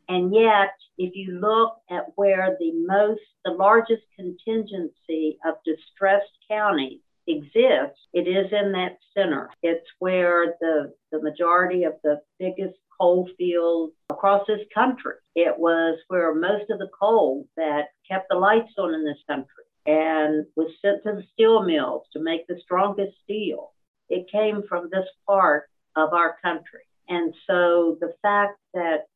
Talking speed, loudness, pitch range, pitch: 150 wpm, -23 LUFS, 165-205 Hz, 180 Hz